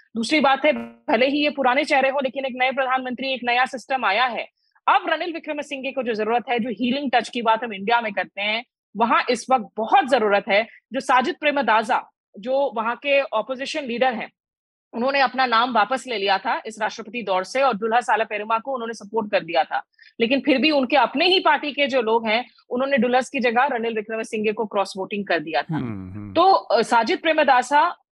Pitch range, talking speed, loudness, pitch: 225-275 Hz, 215 wpm, -21 LUFS, 245 Hz